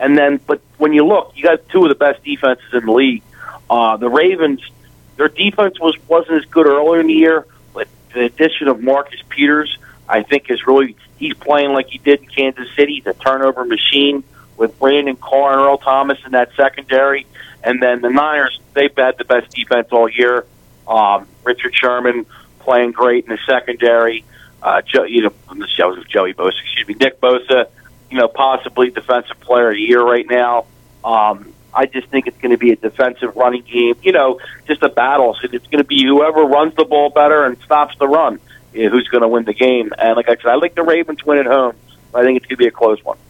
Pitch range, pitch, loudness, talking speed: 120-145 Hz, 135 Hz, -14 LUFS, 225 wpm